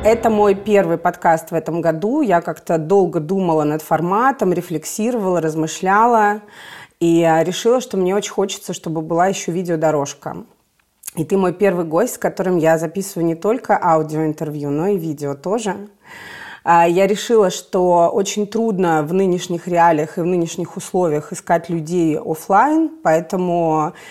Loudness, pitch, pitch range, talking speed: -17 LUFS, 175 Hz, 165-200 Hz, 140 wpm